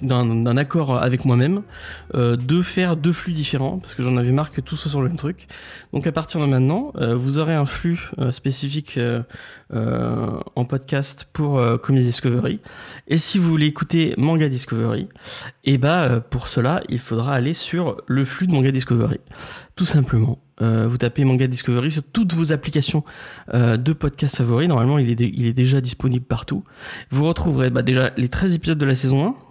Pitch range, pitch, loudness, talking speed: 125-155 Hz, 135 Hz, -20 LUFS, 200 wpm